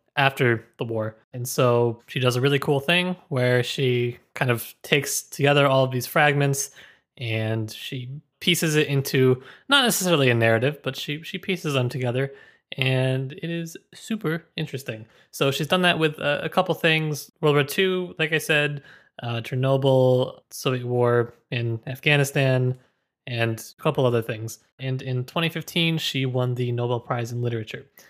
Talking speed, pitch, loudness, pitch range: 165 wpm, 135 Hz, -23 LUFS, 125-155 Hz